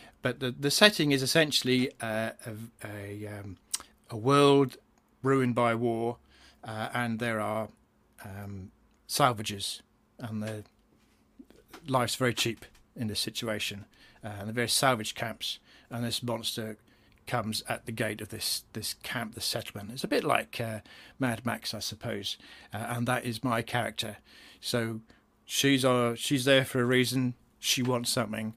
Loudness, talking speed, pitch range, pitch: -29 LUFS, 160 wpm, 110-125 Hz, 115 Hz